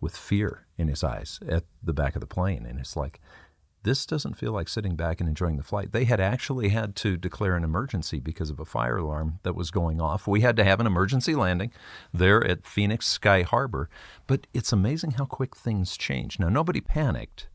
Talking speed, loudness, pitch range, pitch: 215 wpm, -27 LUFS, 80-110 Hz, 95 Hz